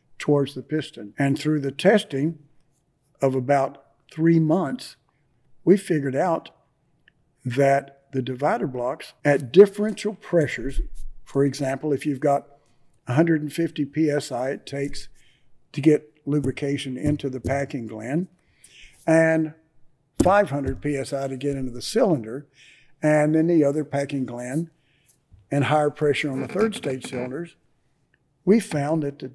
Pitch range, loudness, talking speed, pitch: 135-155 Hz, -23 LUFS, 130 wpm, 145 Hz